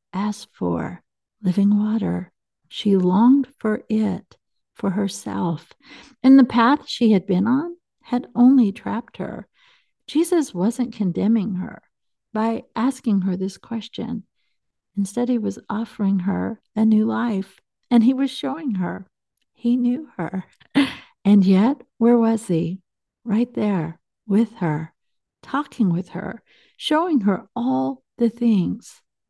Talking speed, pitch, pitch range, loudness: 130 wpm, 220 Hz, 195-245 Hz, -21 LUFS